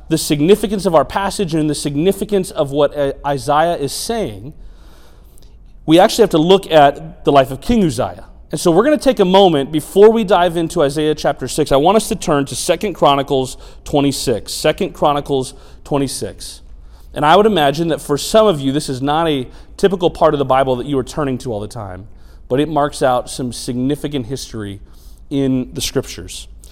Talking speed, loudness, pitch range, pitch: 195 wpm, -15 LUFS, 125-170 Hz, 145 Hz